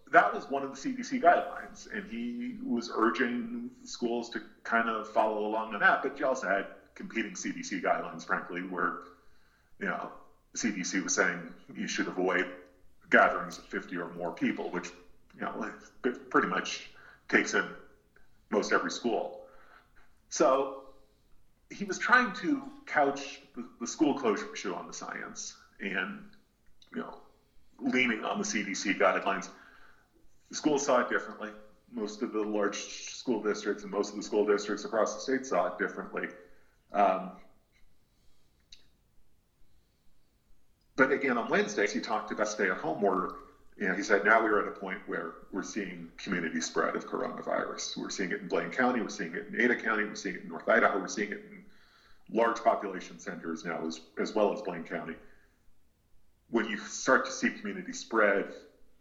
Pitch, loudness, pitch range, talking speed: 110 Hz, -31 LUFS, 90-140 Hz, 165 wpm